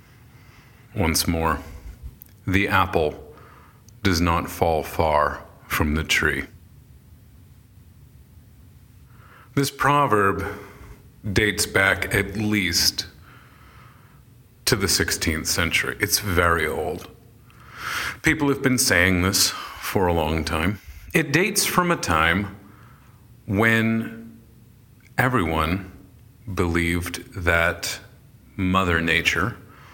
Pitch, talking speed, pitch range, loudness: 100 Hz, 90 wpm, 85-120 Hz, -21 LUFS